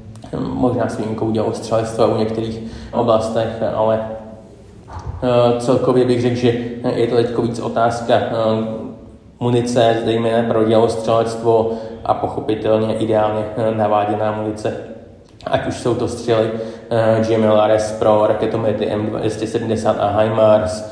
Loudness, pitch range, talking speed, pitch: -17 LUFS, 110-115 Hz, 110 wpm, 110 Hz